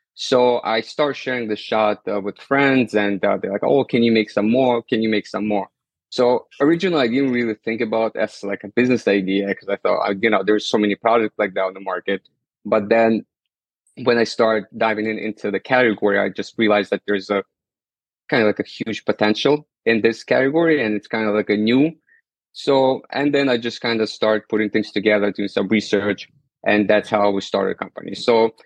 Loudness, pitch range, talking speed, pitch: -19 LUFS, 105-125 Hz, 220 wpm, 110 Hz